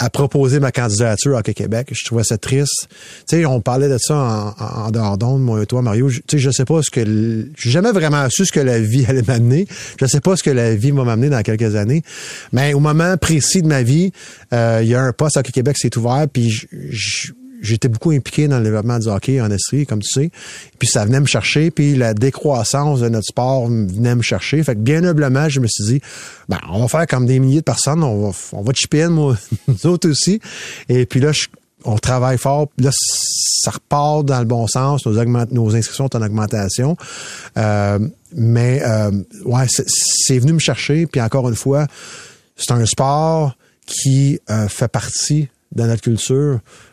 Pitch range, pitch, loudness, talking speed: 115-145 Hz, 130 Hz, -16 LUFS, 220 wpm